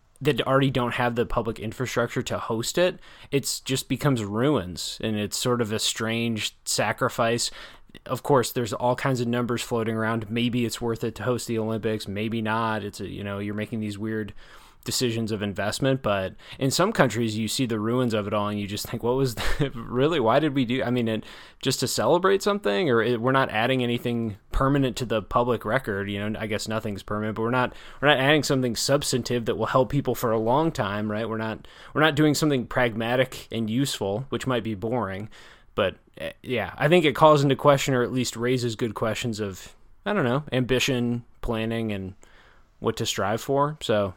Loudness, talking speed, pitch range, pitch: -25 LUFS, 210 wpm, 110-130 Hz, 120 Hz